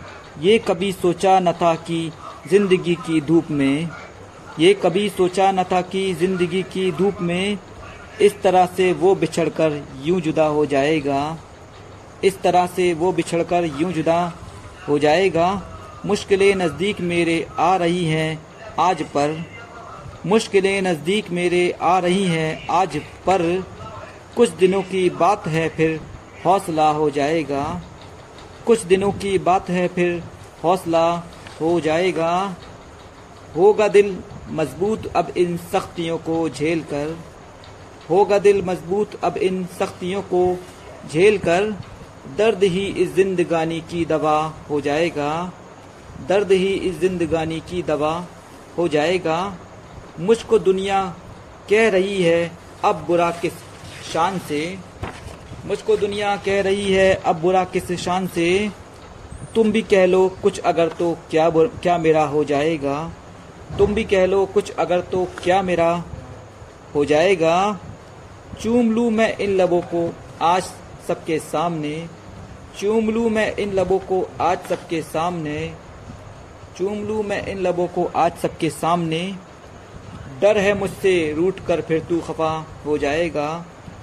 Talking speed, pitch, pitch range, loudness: 135 wpm, 175 Hz, 155-190 Hz, -20 LUFS